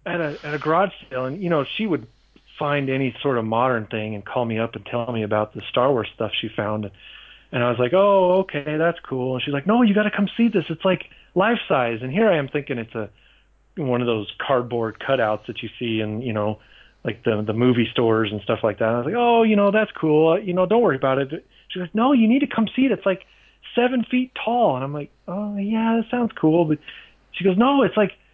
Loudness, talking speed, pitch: -21 LUFS, 260 wpm, 145 Hz